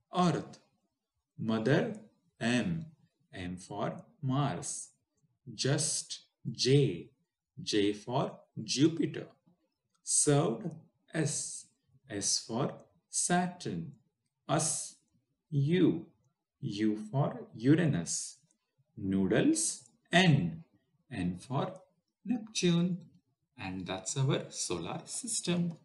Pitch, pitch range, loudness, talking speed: 145 Hz, 120-170 Hz, -32 LUFS, 70 wpm